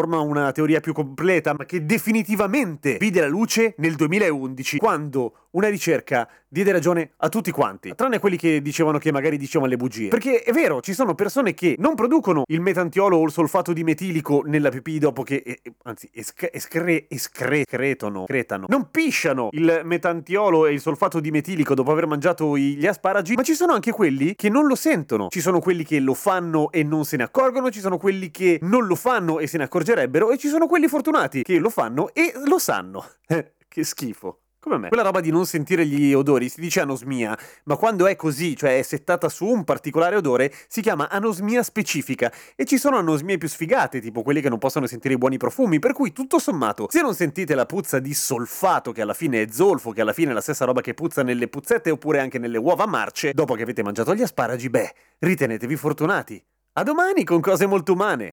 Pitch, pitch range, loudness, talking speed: 165 Hz, 145-205 Hz, -21 LUFS, 210 wpm